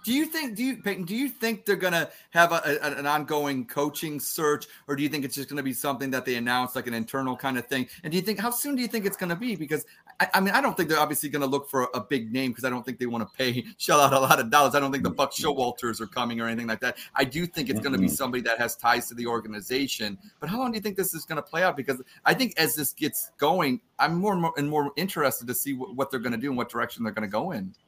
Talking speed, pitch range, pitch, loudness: 325 wpm, 125-180 Hz, 145 Hz, -26 LUFS